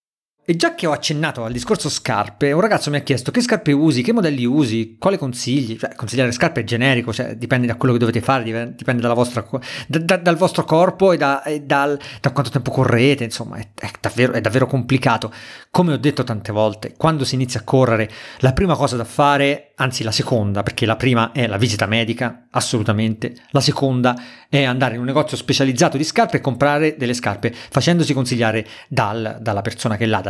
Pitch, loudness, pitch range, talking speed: 130 Hz, -18 LUFS, 115-145 Hz, 205 wpm